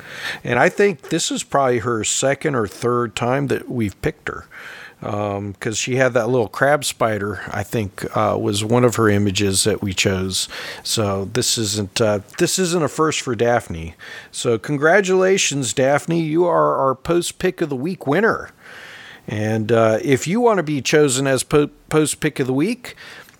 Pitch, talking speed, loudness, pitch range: 125 Hz, 180 wpm, -19 LUFS, 110-155 Hz